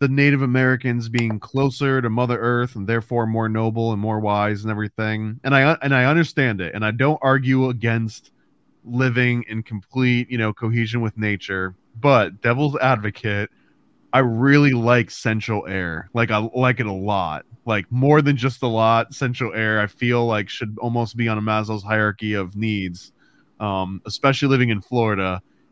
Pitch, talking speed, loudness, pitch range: 115 Hz, 175 wpm, -20 LUFS, 105-130 Hz